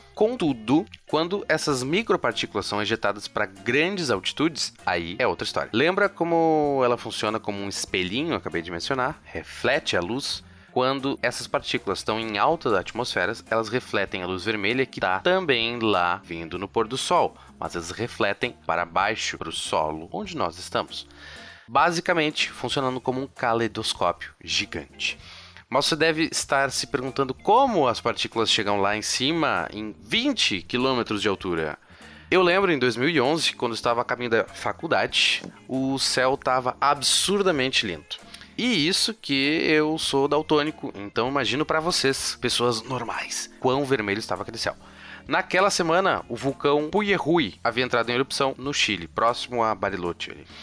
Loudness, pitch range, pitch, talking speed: -24 LUFS, 105-145 Hz, 125 Hz, 155 wpm